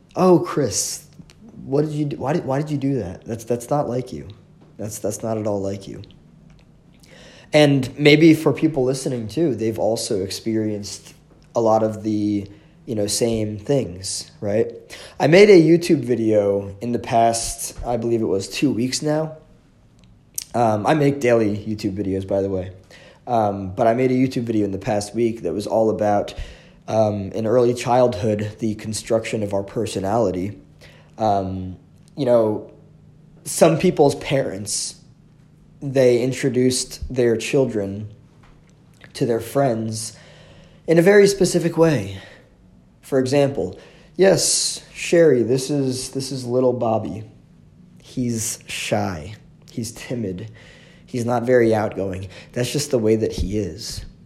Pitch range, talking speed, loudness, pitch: 105-150 Hz, 150 wpm, -20 LUFS, 120 Hz